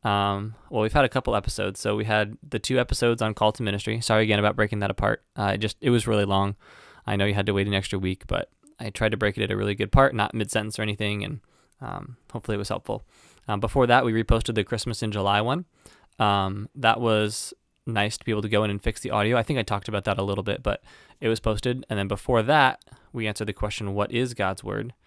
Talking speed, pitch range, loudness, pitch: 265 wpm, 100-115 Hz, -25 LUFS, 105 Hz